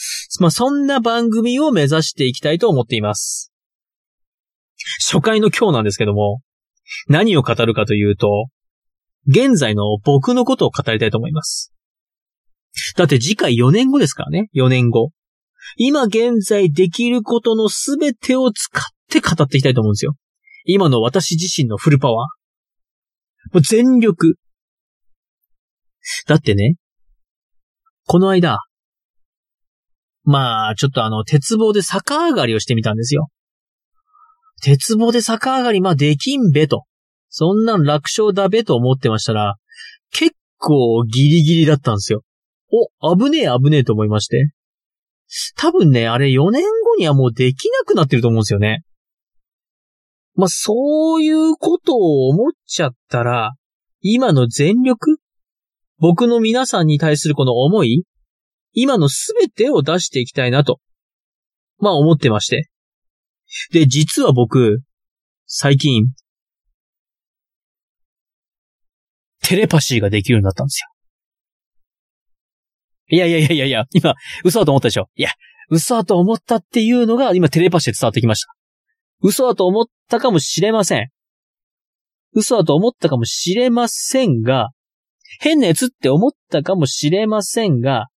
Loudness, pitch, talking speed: -15 LUFS, 160 Hz, 275 characters per minute